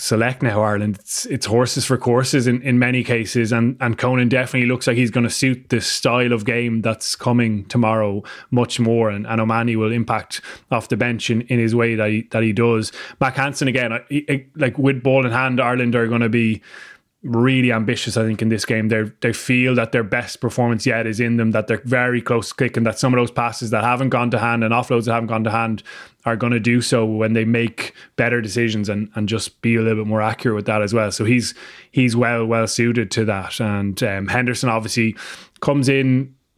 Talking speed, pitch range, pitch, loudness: 230 wpm, 110-125 Hz, 120 Hz, -19 LUFS